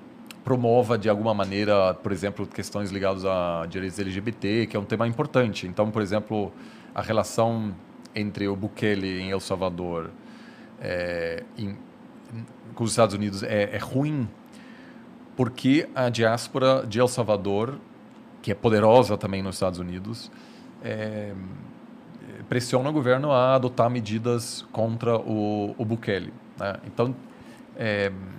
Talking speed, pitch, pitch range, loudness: 135 wpm, 110 Hz, 100-120 Hz, -25 LUFS